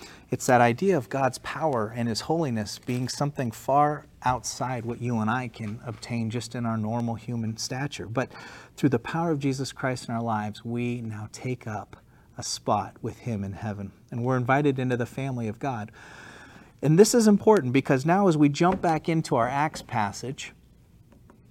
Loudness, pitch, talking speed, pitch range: -26 LUFS, 120 Hz, 185 wpm, 110-140 Hz